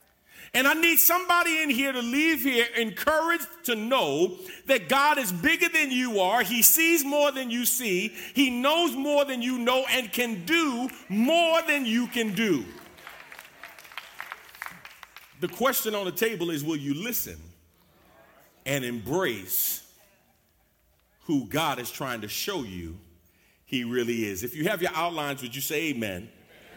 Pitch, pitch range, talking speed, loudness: 240 Hz, 170-290 Hz, 155 wpm, -25 LUFS